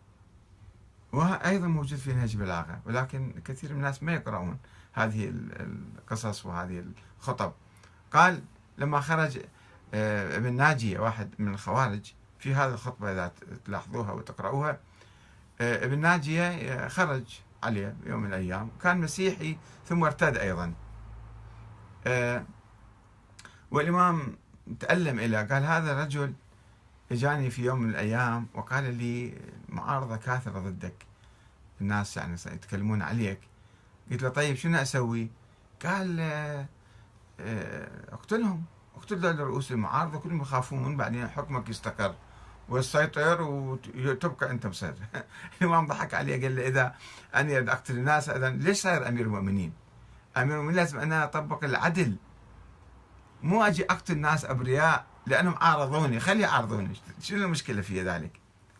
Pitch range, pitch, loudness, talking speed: 105-145 Hz, 120 Hz, -29 LUFS, 115 wpm